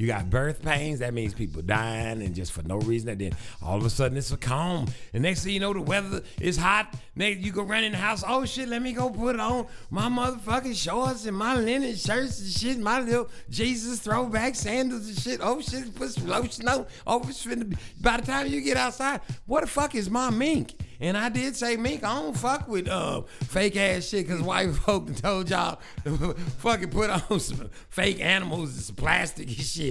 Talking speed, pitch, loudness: 215 wpm, 195 Hz, -27 LUFS